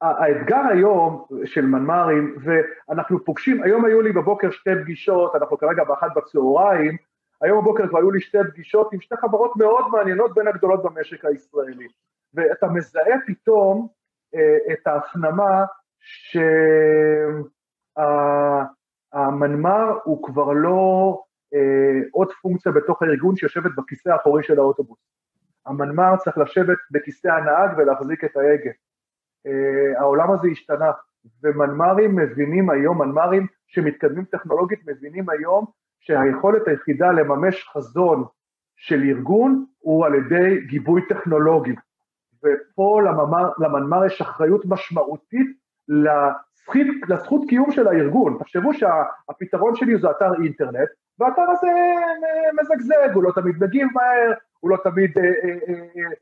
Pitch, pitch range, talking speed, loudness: 180 Hz, 150-205 Hz, 115 wpm, -19 LUFS